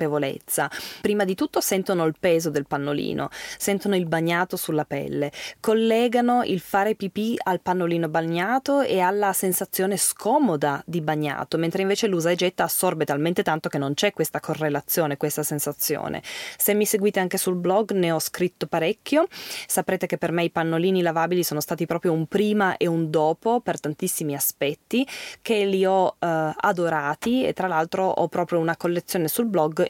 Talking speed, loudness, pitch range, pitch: 165 wpm, -23 LUFS, 160-200 Hz, 175 Hz